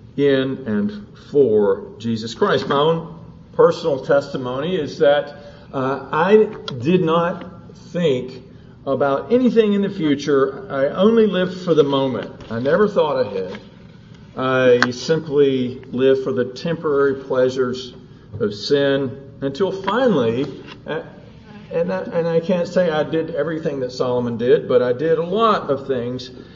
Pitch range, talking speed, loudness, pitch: 135-190 Hz, 140 wpm, -19 LUFS, 150 Hz